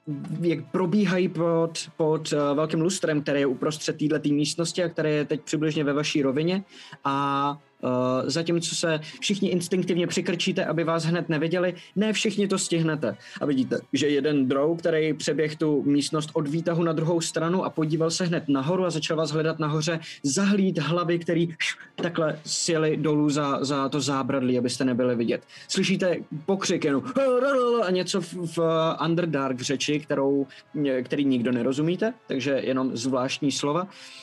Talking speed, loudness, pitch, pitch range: 155 wpm, -25 LUFS, 160 Hz, 145-175 Hz